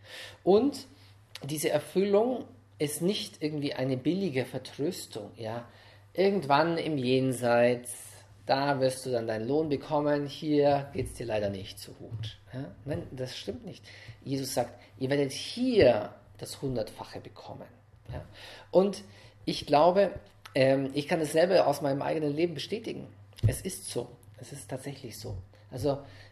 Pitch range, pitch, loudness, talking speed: 110-150 Hz, 130 Hz, -29 LUFS, 140 wpm